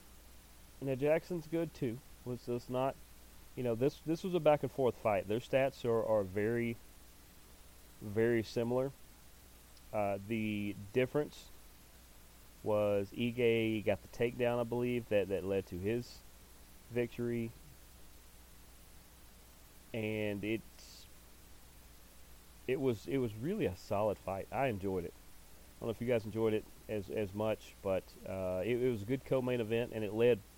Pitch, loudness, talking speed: 105 Hz, -36 LUFS, 150 wpm